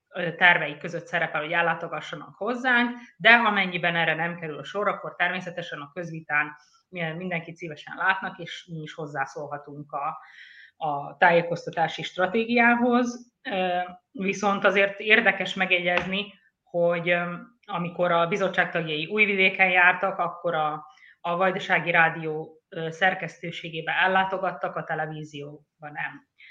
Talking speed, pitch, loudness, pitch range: 110 wpm, 175 Hz, -24 LUFS, 160-190 Hz